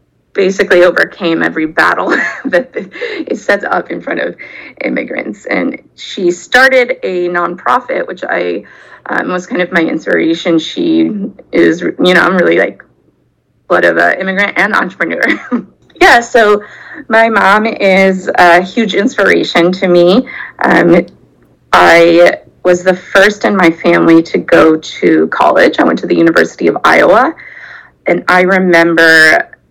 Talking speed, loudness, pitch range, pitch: 140 wpm, -9 LUFS, 170-225 Hz, 185 Hz